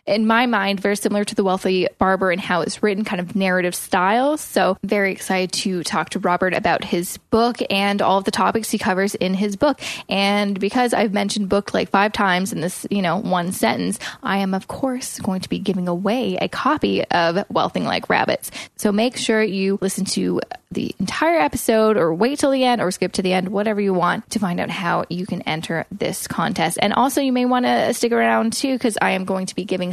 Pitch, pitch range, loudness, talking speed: 200 Hz, 185-225 Hz, -20 LUFS, 225 wpm